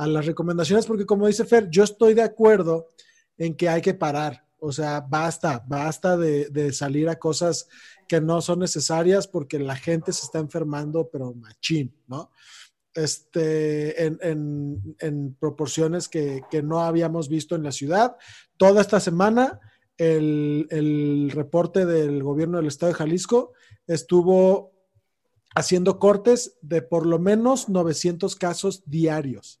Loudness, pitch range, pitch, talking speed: -22 LUFS, 150-185 Hz, 165 Hz, 150 wpm